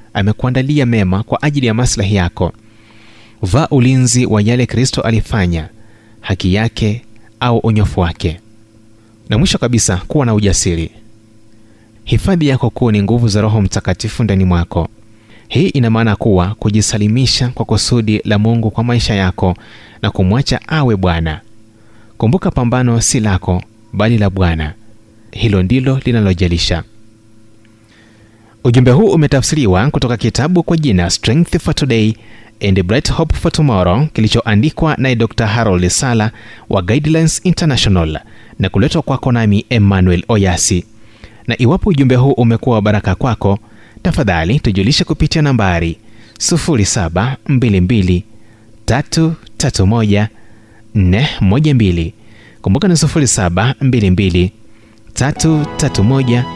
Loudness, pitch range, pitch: -13 LUFS, 105-125 Hz, 110 Hz